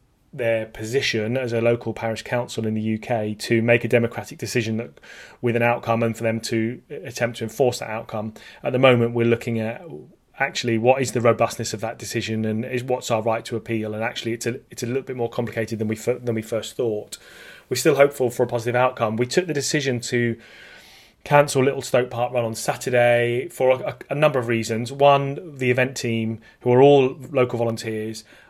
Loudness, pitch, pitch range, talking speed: -22 LUFS, 120 Hz, 115-125 Hz, 210 wpm